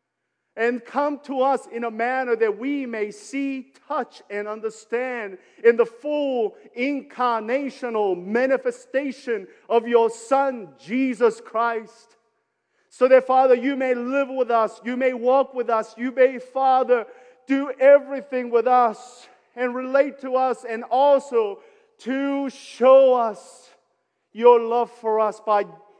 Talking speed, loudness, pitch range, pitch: 135 wpm, -22 LUFS, 230-265 Hz, 250 Hz